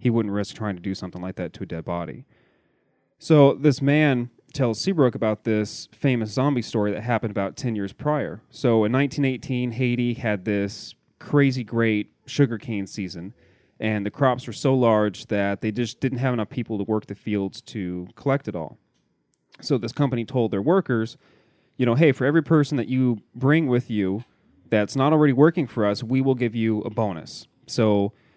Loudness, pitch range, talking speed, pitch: -23 LUFS, 105-135 Hz, 190 wpm, 115 Hz